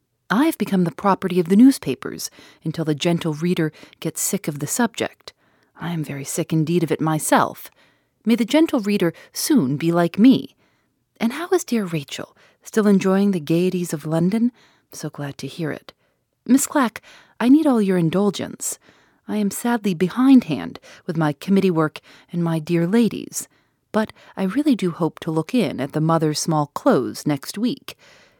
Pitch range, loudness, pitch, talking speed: 160-230 Hz, -20 LUFS, 180 Hz, 175 wpm